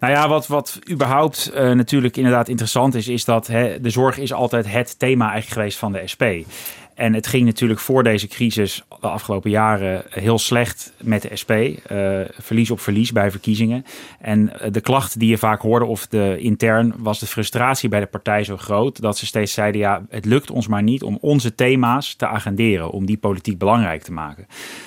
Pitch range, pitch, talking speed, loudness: 105-125 Hz, 115 Hz, 205 wpm, -19 LUFS